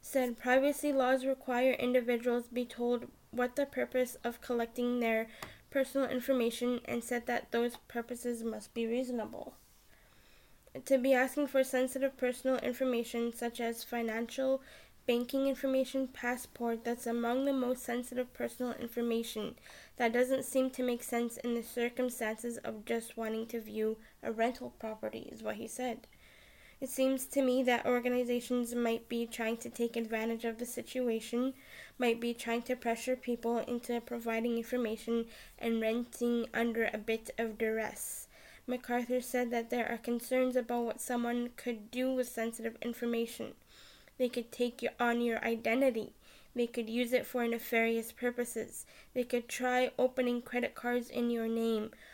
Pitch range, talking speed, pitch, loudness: 230-255 Hz, 150 wpm, 240 Hz, -35 LUFS